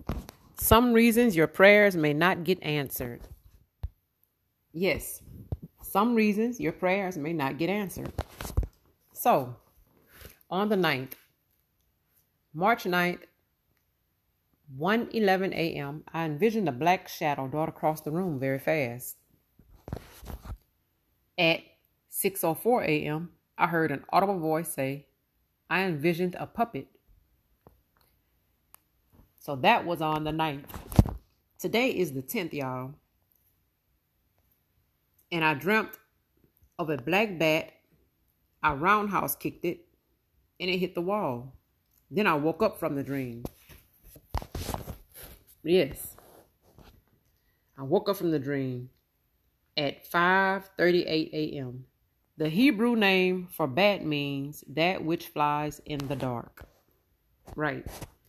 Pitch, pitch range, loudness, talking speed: 155 Hz, 130-185 Hz, -27 LUFS, 110 wpm